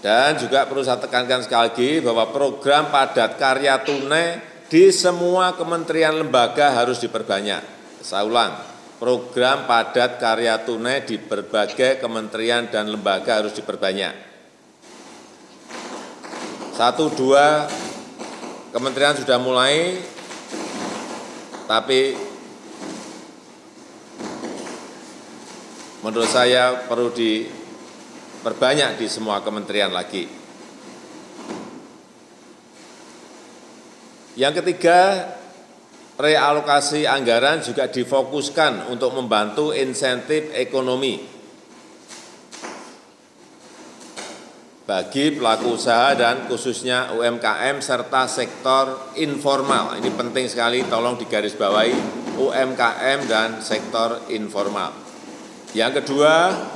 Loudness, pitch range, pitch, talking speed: -19 LUFS, 120-145 Hz, 130 Hz, 80 wpm